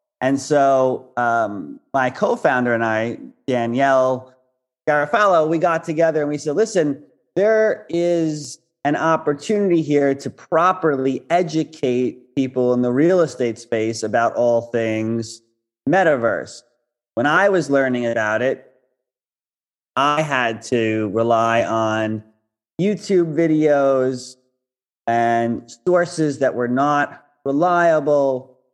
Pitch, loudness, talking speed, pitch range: 130 Hz, -19 LUFS, 110 wpm, 120-155 Hz